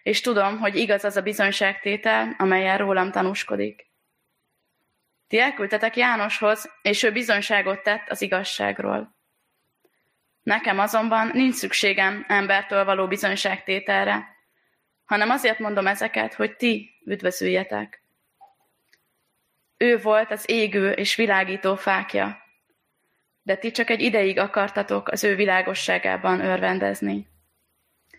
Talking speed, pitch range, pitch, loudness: 105 wpm, 185-215 Hz, 200 Hz, -22 LUFS